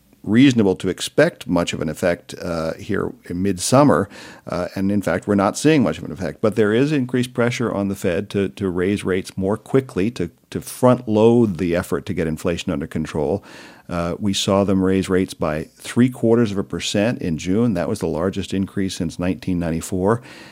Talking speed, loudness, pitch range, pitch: 200 wpm, -20 LUFS, 90-110 Hz, 95 Hz